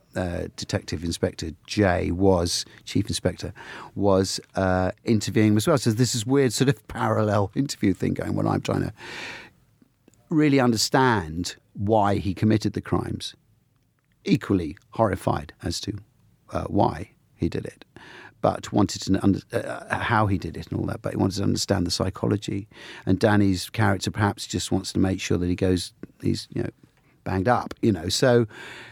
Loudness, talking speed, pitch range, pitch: -24 LUFS, 175 wpm, 95-115 Hz, 100 Hz